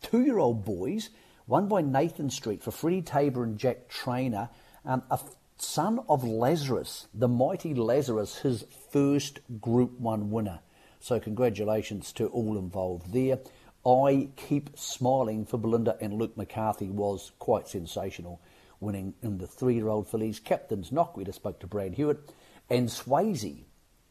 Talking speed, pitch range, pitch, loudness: 155 wpm, 105-135 Hz, 115 Hz, -30 LUFS